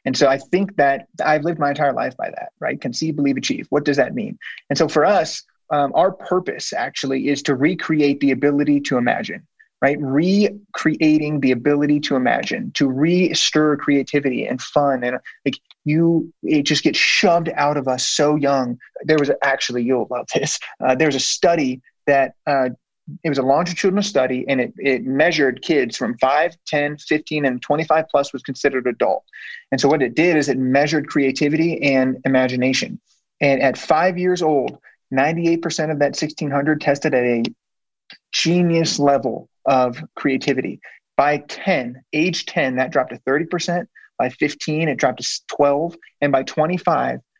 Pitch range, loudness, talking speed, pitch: 135-160 Hz, -19 LUFS, 170 wpm, 145 Hz